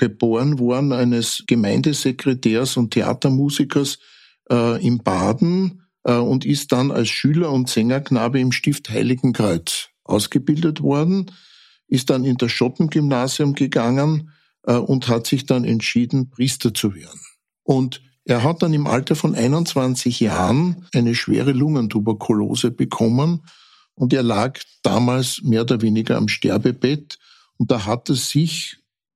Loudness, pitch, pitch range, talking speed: -19 LUFS, 130 Hz, 120-145 Hz, 130 wpm